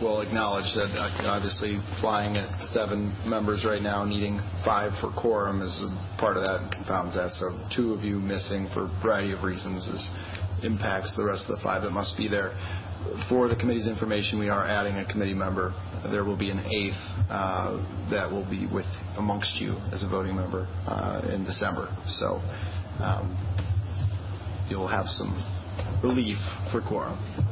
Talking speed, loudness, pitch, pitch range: 175 wpm, -29 LUFS, 100 Hz, 95-105 Hz